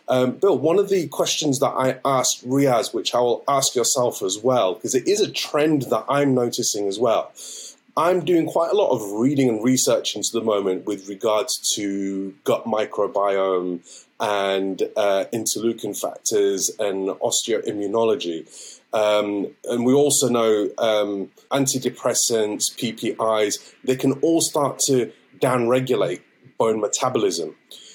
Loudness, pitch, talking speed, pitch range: -21 LUFS, 120 Hz, 140 wpm, 100-140 Hz